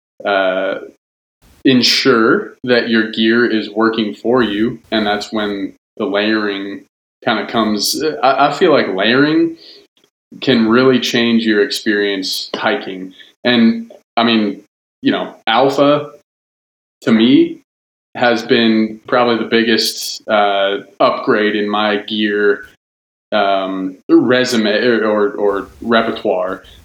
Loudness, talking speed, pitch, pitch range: -14 LUFS, 115 wpm, 110 Hz, 100-120 Hz